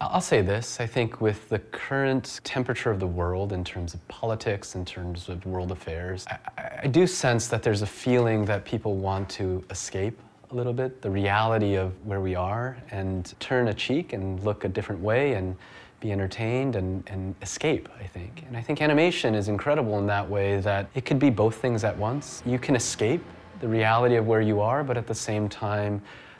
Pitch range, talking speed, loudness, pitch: 95-120 Hz, 210 wpm, -27 LUFS, 105 Hz